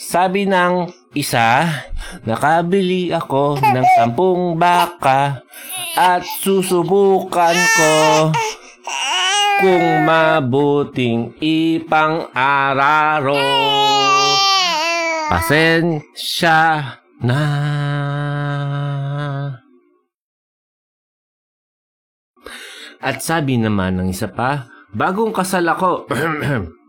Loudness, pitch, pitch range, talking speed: -16 LUFS, 160 Hz, 140-185 Hz, 55 wpm